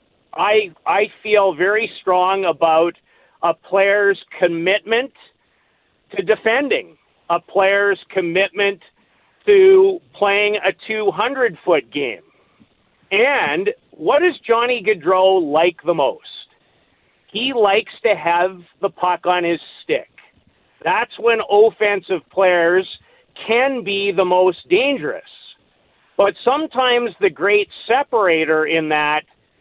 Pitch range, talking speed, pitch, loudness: 180-230 Hz, 110 wpm, 200 Hz, -17 LUFS